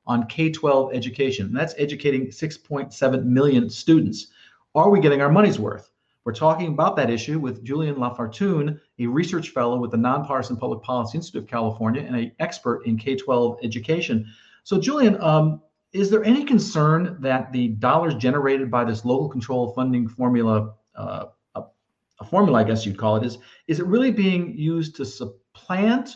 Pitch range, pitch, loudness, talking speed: 120-160 Hz, 135 Hz, -22 LUFS, 170 wpm